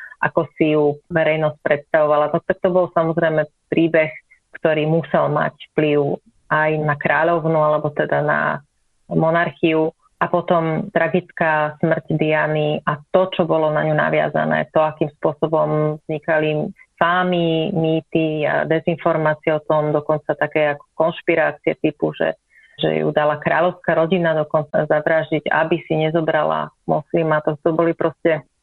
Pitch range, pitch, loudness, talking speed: 150-165 Hz, 155 Hz, -19 LUFS, 140 wpm